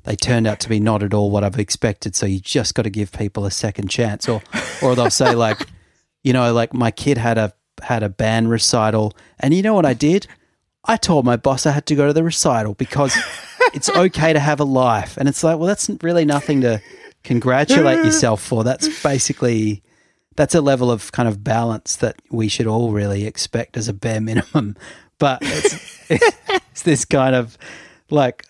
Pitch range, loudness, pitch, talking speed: 110-145 Hz, -18 LUFS, 120 Hz, 205 wpm